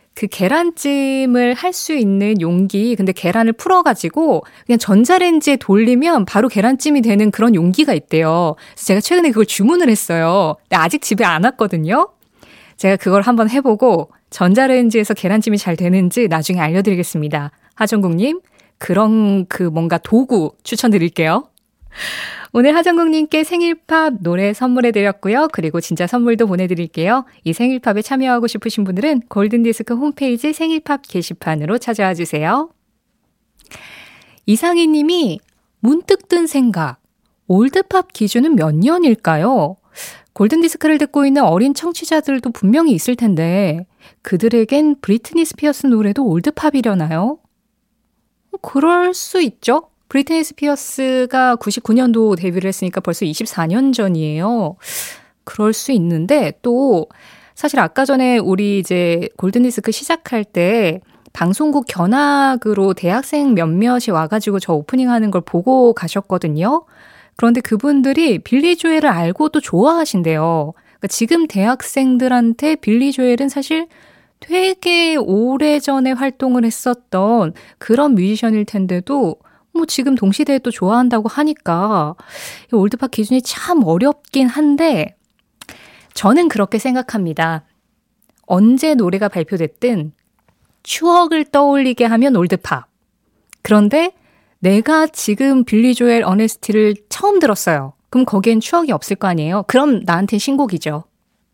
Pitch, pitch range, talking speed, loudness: 230 Hz, 195-280 Hz, 305 characters per minute, -15 LUFS